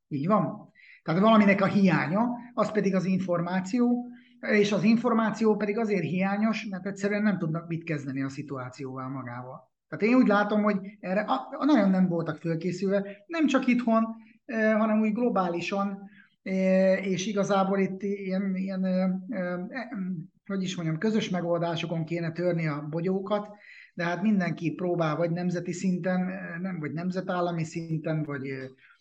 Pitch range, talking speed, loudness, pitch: 170-210 Hz, 140 wpm, -27 LUFS, 190 Hz